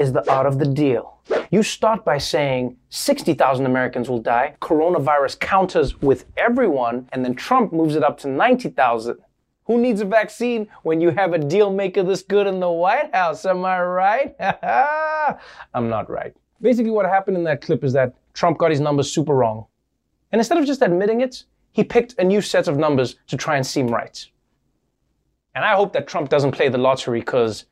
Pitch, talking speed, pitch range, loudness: 170 Hz, 195 wpm, 135-215 Hz, -19 LUFS